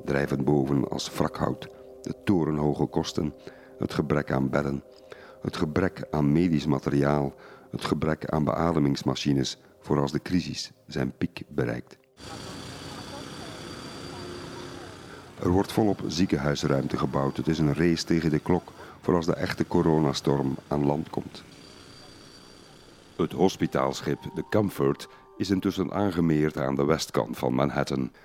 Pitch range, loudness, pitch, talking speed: 70-80 Hz, -27 LUFS, 75 Hz, 125 wpm